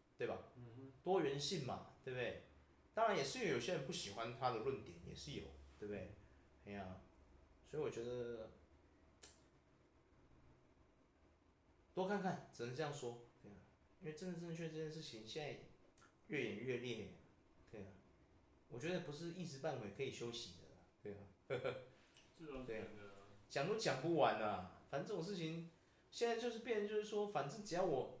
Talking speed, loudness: 235 characters per minute, -45 LUFS